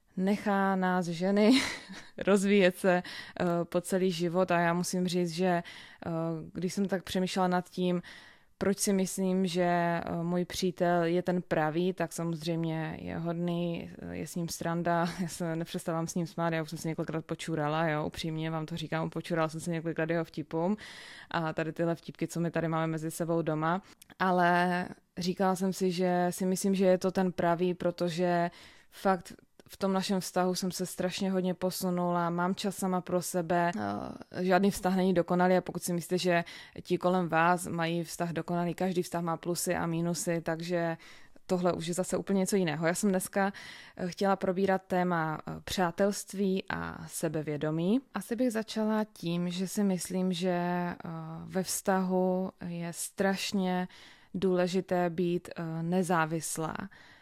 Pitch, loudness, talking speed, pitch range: 180 Hz, -31 LUFS, 160 wpm, 170-185 Hz